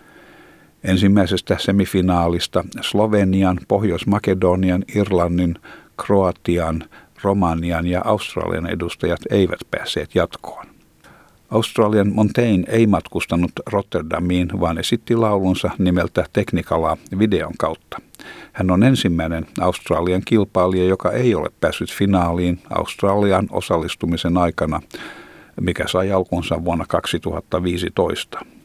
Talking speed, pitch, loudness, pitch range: 90 wpm, 90 Hz, -19 LUFS, 85-100 Hz